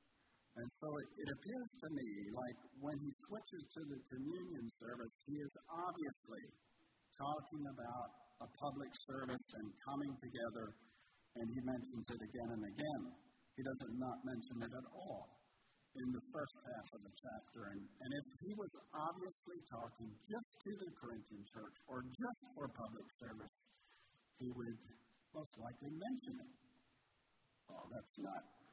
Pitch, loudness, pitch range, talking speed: 130 Hz, -50 LUFS, 115-150 Hz, 155 wpm